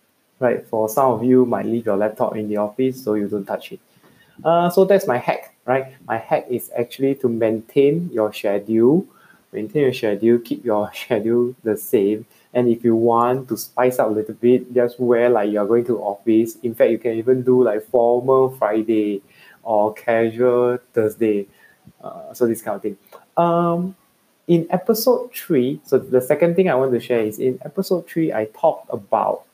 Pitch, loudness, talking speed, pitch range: 120 Hz, -19 LUFS, 190 wpm, 110-130 Hz